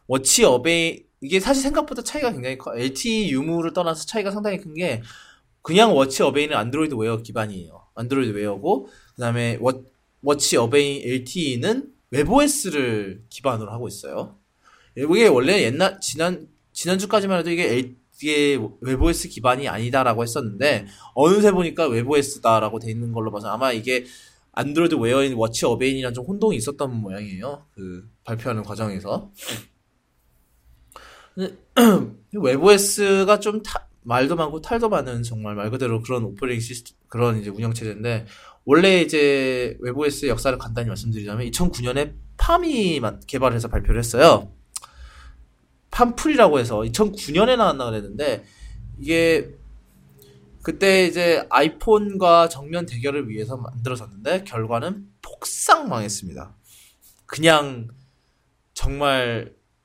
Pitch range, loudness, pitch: 110-165 Hz, -21 LUFS, 130 Hz